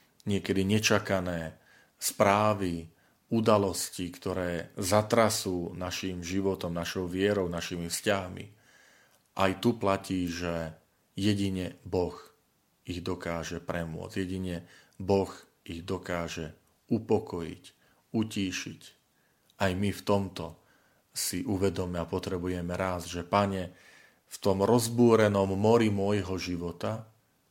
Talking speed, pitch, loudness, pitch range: 95 wpm, 95 Hz, -30 LUFS, 90-100 Hz